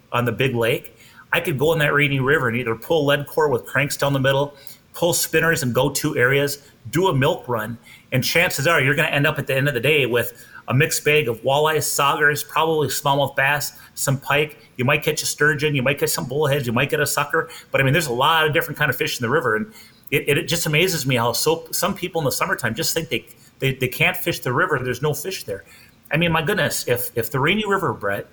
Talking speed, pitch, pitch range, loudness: 260 wpm, 145 Hz, 130-160 Hz, -20 LUFS